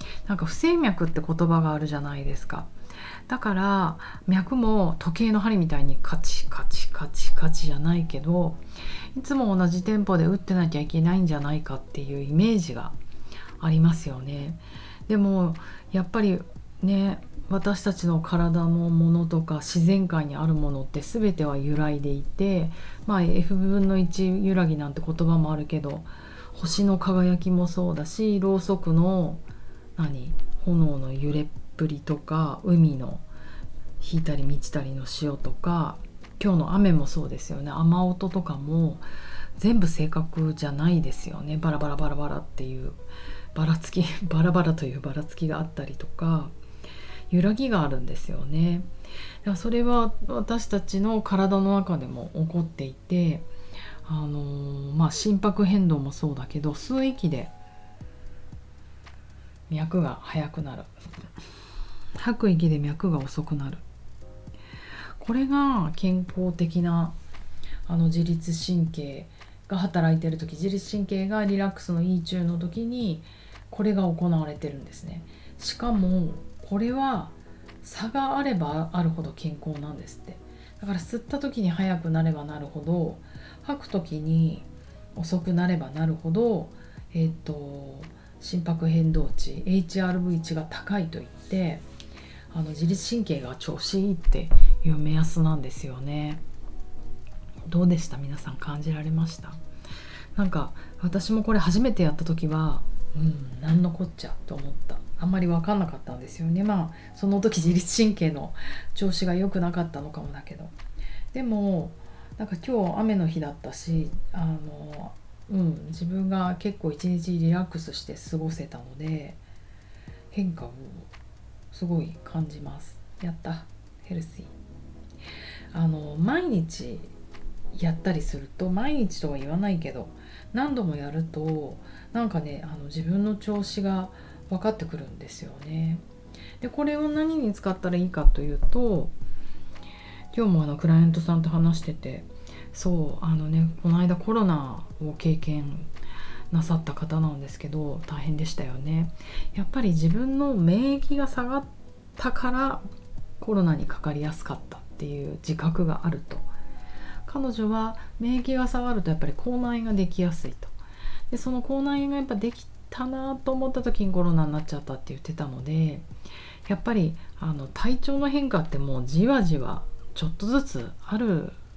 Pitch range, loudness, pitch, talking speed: 145-190 Hz, -27 LUFS, 165 Hz, 295 characters per minute